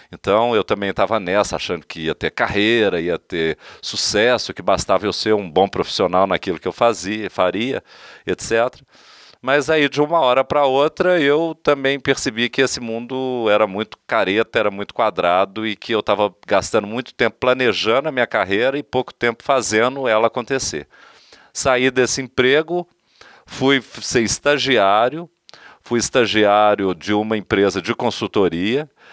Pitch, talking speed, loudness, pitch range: 120 Hz, 155 wpm, -18 LUFS, 105-135 Hz